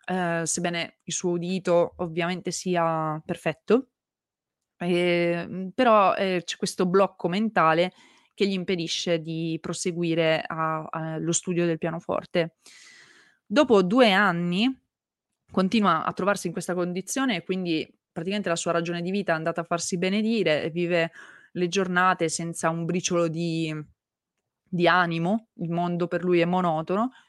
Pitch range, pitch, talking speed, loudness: 170-190 Hz, 175 Hz, 135 wpm, -25 LUFS